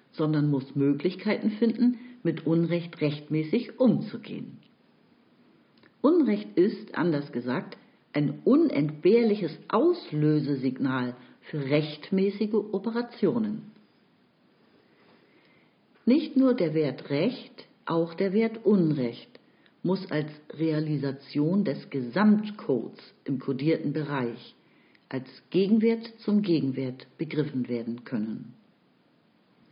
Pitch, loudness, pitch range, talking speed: 165 Hz, -27 LUFS, 145-220 Hz, 85 wpm